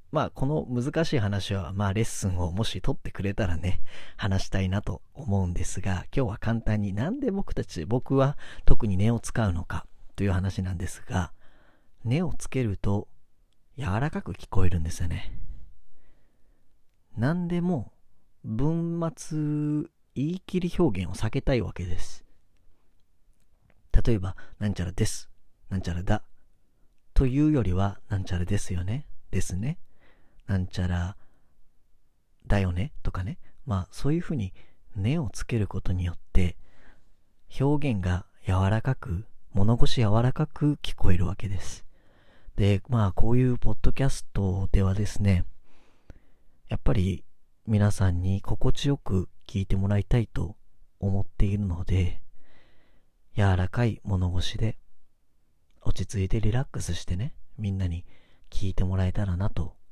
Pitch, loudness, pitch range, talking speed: 100 Hz, -29 LUFS, 90-120 Hz, 275 characters per minute